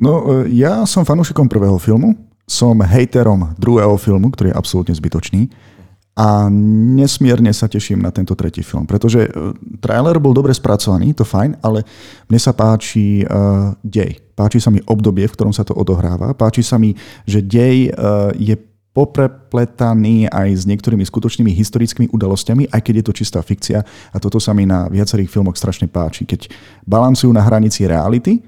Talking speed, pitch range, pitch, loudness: 160 wpm, 100-120 Hz, 110 Hz, -14 LUFS